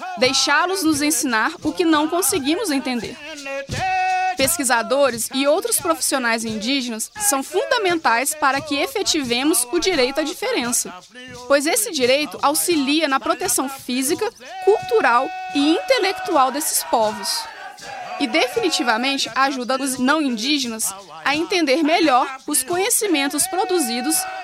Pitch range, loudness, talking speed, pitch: 265-360 Hz, -19 LUFS, 115 wpm, 295 Hz